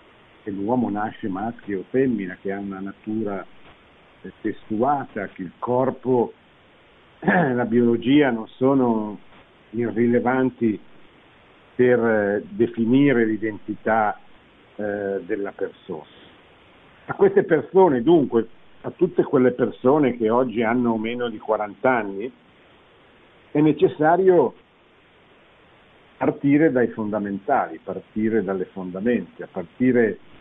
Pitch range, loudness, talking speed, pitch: 105-130 Hz, -22 LUFS, 100 wpm, 115 Hz